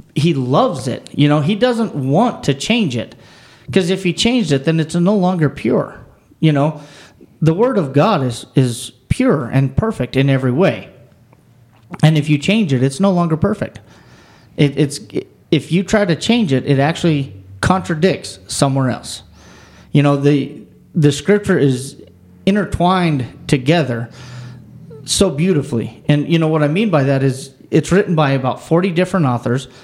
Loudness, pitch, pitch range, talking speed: -16 LUFS, 145 Hz, 130-175 Hz, 165 wpm